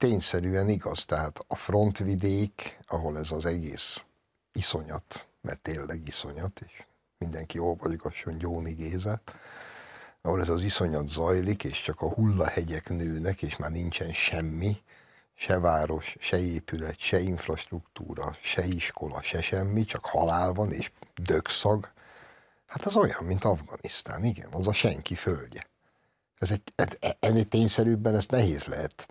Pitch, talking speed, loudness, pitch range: 90 Hz, 130 wpm, -29 LUFS, 80-105 Hz